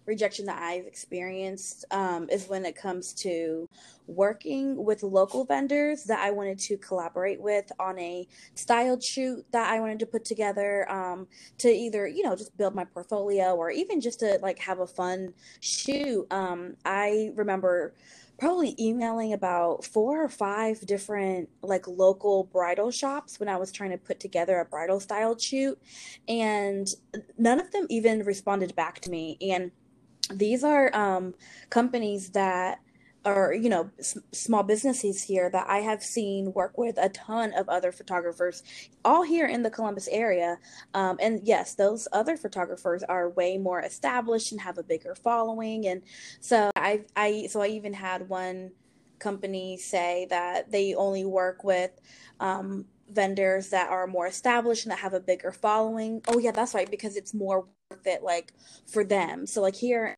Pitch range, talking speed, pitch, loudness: 185-220 Hz, 170 wpm, 200 Hz, -28 LUFS